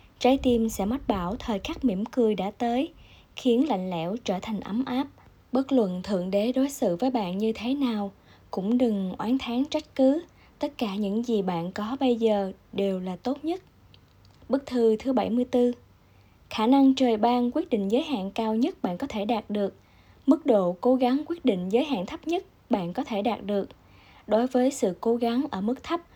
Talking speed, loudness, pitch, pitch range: 205 wpm, -26 LUFS, 240 Hz, 205-265 Hz